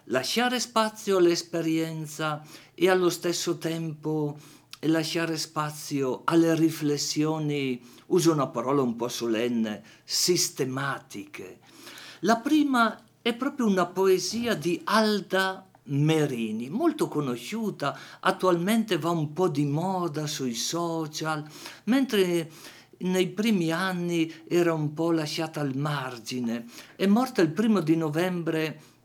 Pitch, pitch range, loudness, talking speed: 165 Hz, 150-185 Hz, -27 LUFS, 110 wpm